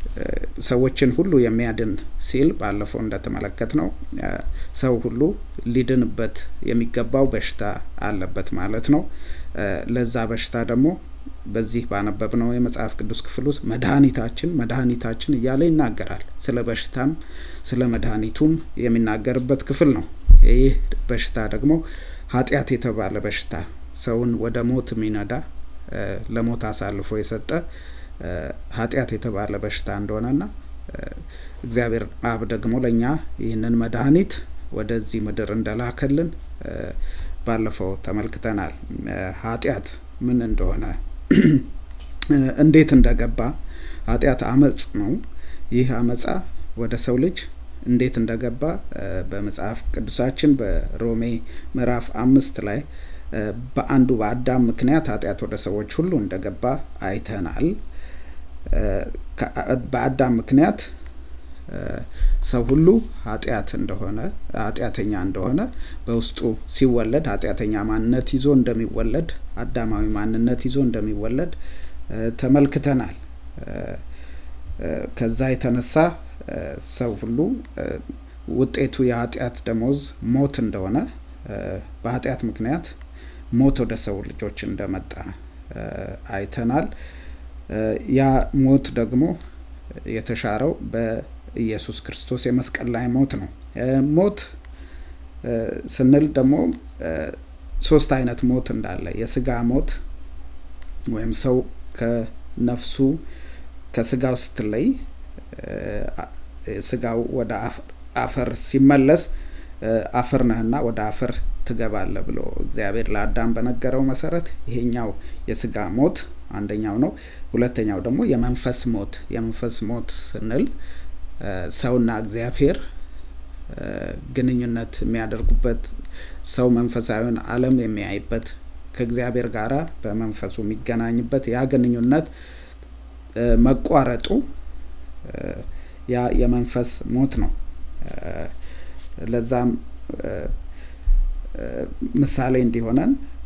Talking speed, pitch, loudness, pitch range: 85 wpm, 115 Hz, -22 LUFS, 80-125 Hz